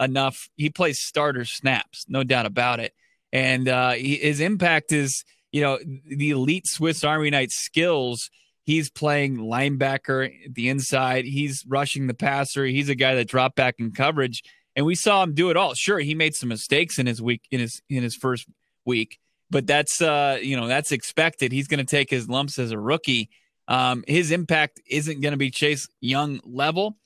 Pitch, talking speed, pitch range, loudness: 140 Hz, 190 wpm, 130-150 Hz, -23 LUFS